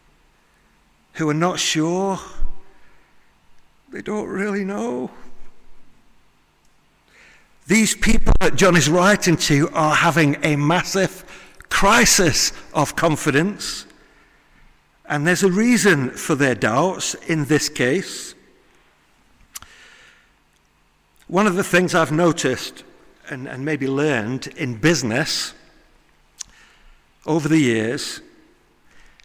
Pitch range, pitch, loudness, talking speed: 140-190 Hz, 160 Hz, -19 LUFS, 95 wpm